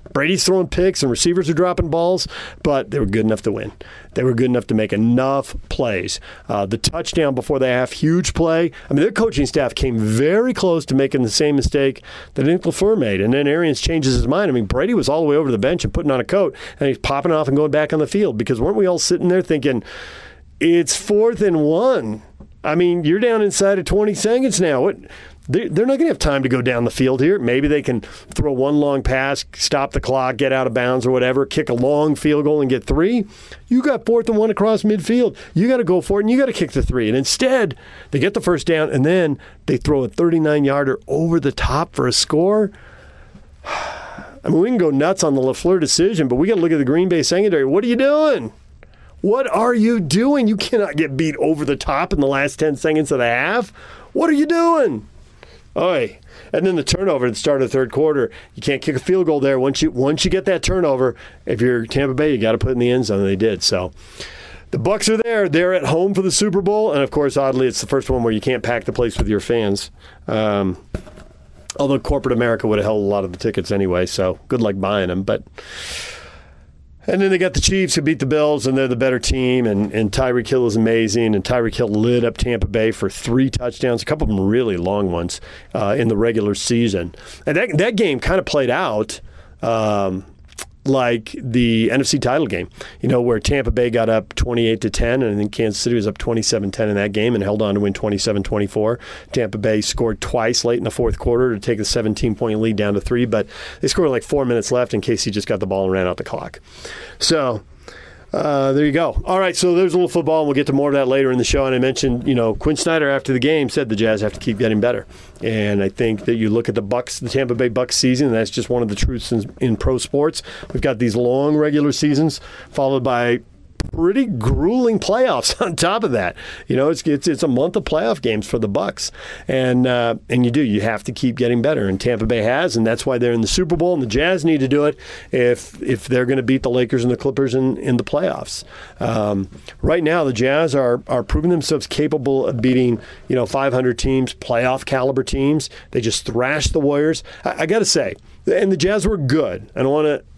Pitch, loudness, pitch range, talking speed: 130 Hz, -18 LUFS, 115-155 Hz, 245 wpm